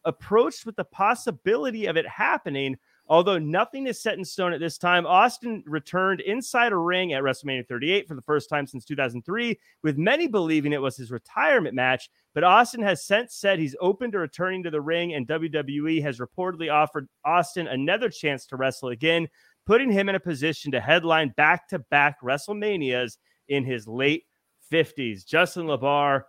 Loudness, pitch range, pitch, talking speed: -24 LUFS, 140-185 Hz, 160 Hz, 175 wpm